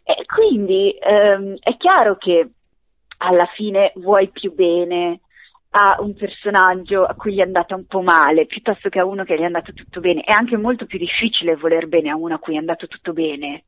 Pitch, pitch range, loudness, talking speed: 185 Hz, 170-205 Hz, -17 LUFS, 205 wpm